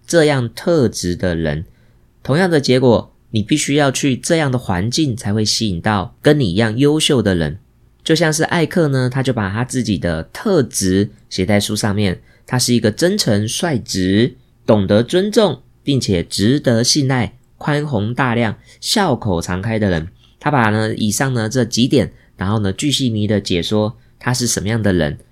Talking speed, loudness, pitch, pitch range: 255 characters per minute, -16 LUFS, 115 Hz, 105-135 Hz